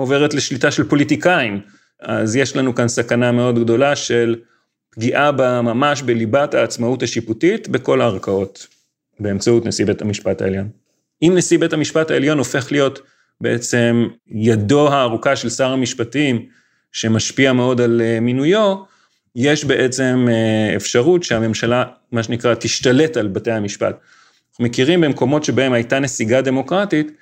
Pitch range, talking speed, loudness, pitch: 115-140 Hz, 130 wpm, -17 LUFS, 125 Hz